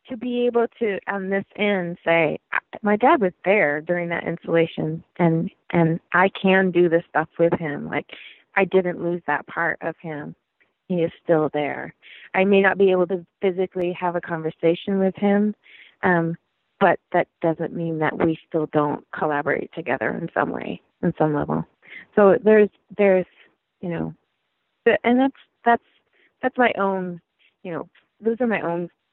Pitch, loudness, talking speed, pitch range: 180 Hz, -22 LUFS, 170 wpm, 165-200 Hz